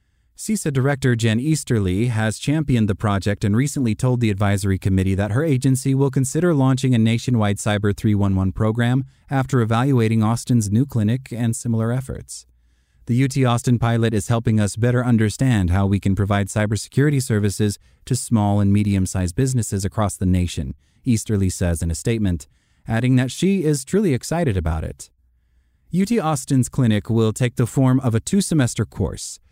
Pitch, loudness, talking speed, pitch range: 115 Hz, -20 LUFS, 165 wpm, 100-130 Hz